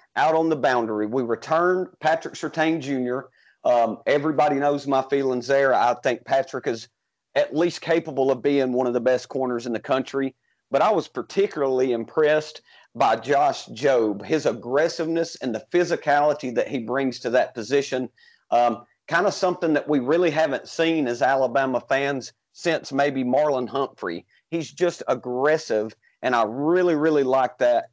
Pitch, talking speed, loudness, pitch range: 140 Hz, 165 wpm, -23 LUFS, 130-160 Hz